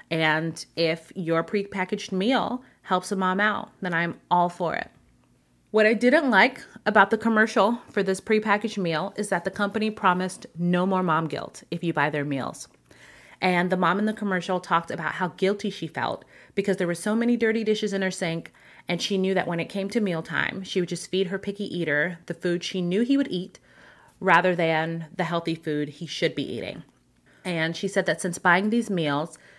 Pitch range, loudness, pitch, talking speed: 165-205 Hz, -25 LUFS, 185 Hz, 205 wpm